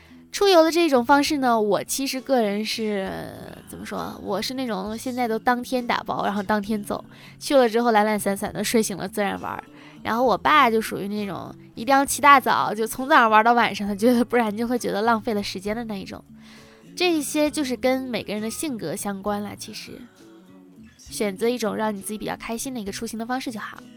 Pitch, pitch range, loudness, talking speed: 225 Hz, 205-255 Hz, -22 LUFS, 320 characters per minute